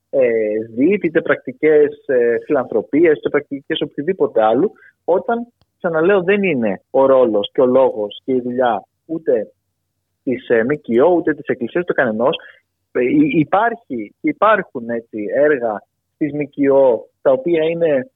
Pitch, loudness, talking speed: 165 Hz, -17 LUFS, 130 wpm